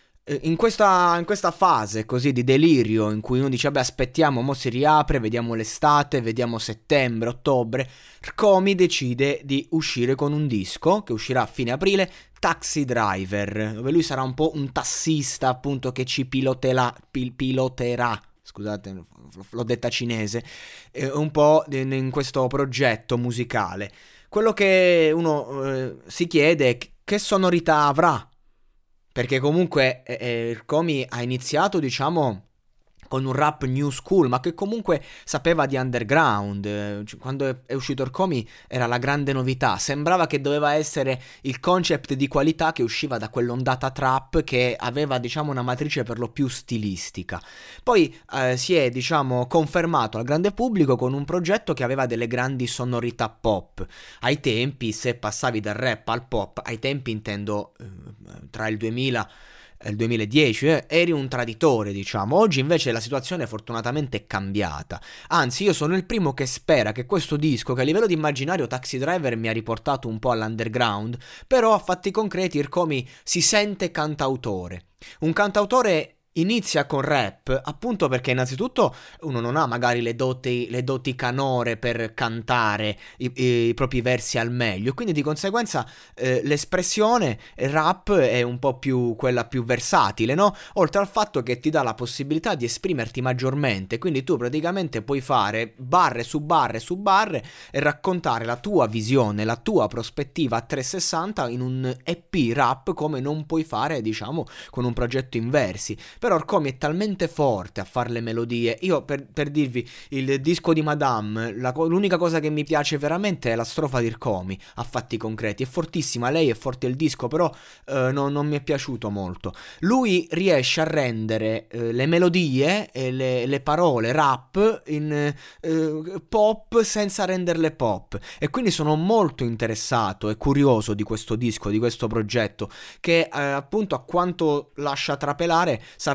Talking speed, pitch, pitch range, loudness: 165 wpm, 135 Hz, 120-155 Hz, -23 LUFS